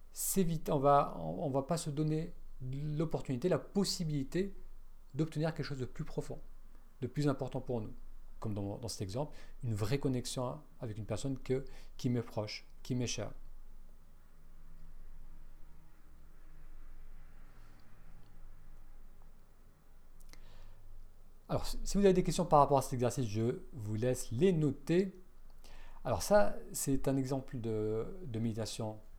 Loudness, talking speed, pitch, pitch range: -36 LUFS, 135 wpm, 125 Hz, 100-150 Hz